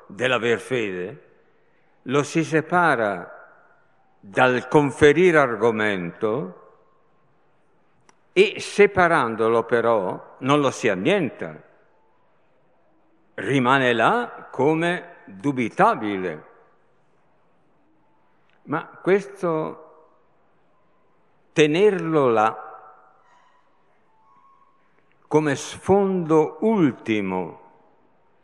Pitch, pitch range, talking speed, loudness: 150 Hz, 115-180 Hz, 55 wpm, -21 LUFS